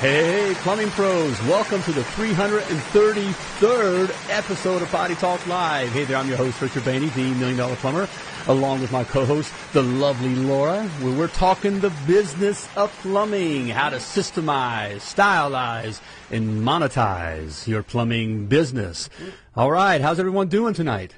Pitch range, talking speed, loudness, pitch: 130-195 Hz, 145 wpm, -22 LUFS, 155 Hz